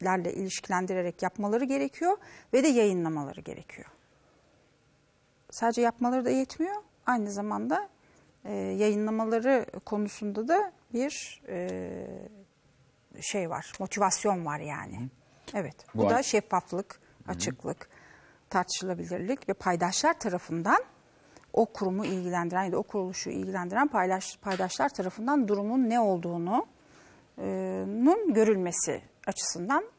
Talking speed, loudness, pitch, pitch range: 100 wpm, -29 LUFS, 200 Hz, 180-245 Hz